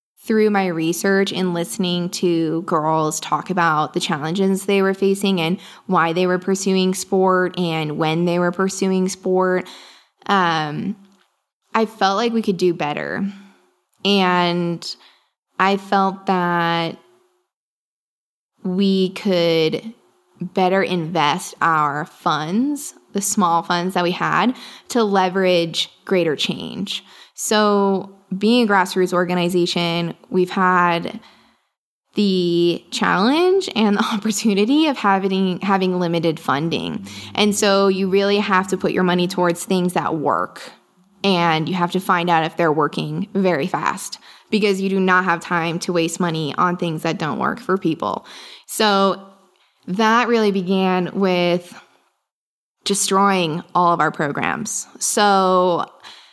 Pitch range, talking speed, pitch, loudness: 175-200 Hz, 130 wpm, 185 Hz, -19 LUFS